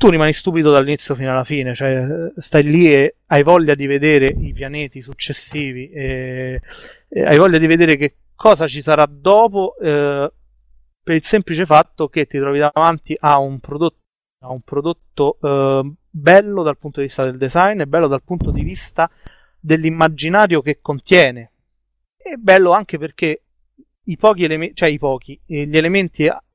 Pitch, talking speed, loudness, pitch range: 150 Hz, 160 wpm, -15 LUFS, 140-165 Hz